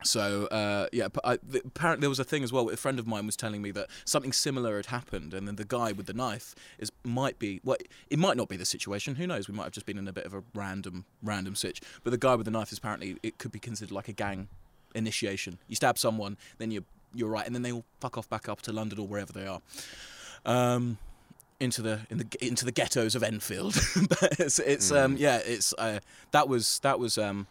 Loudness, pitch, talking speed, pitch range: -31 LUFS, 110 Hz, 255 wpm, 100-125 Hz